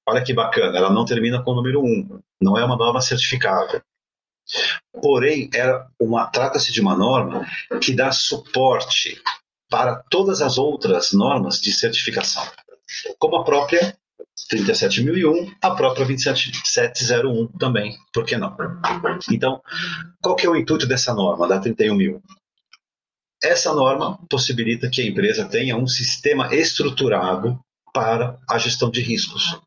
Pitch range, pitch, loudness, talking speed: 120-195 Hz, 130 Hz, -19 LUFS, 140 wpm